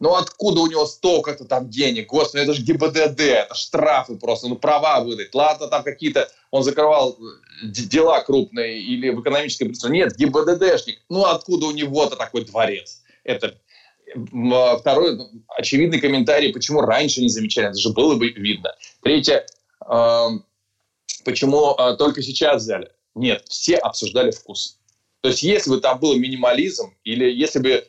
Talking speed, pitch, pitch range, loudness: 145 wpm, 140 Hz, 120-155 Hz, -19 LUFS